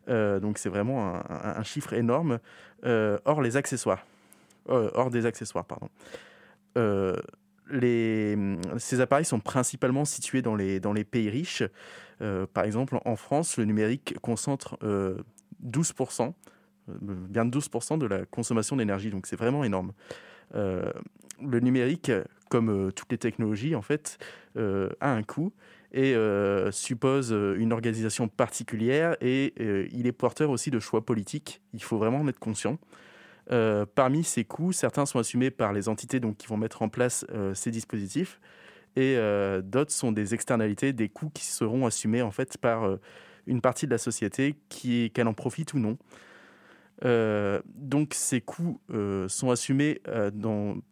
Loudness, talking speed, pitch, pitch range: -28 LUFS, 165 wpm, 120 Hz, 105-130 Hz